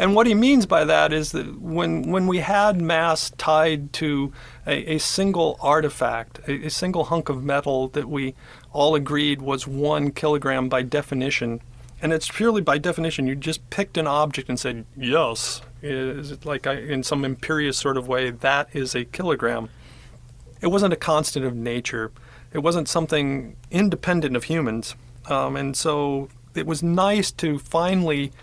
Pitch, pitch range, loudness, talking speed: 145 Hz, 130-160 Hz, -23 LUFS, 170 wpm